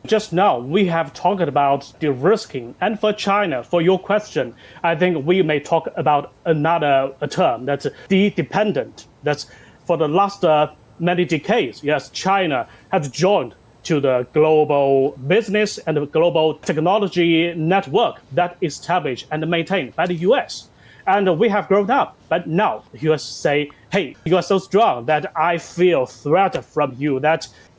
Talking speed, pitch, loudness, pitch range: 165 wpm, 165 Hz, -19 LUFS, 145-190 Hz